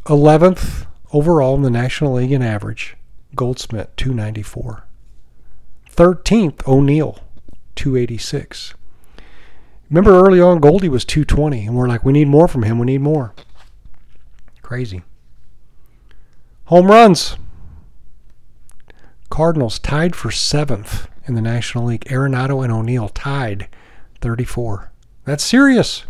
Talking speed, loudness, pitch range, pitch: 115 wpm, -15 LUFS, 110-150 Hz, 125 Hz